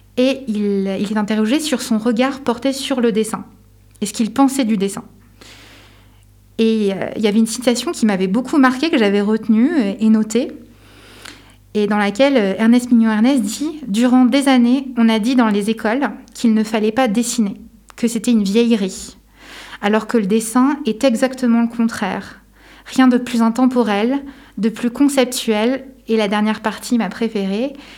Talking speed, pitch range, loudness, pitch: 170 wpm, 215-255 Hz, -17 LUFS, 230 Hz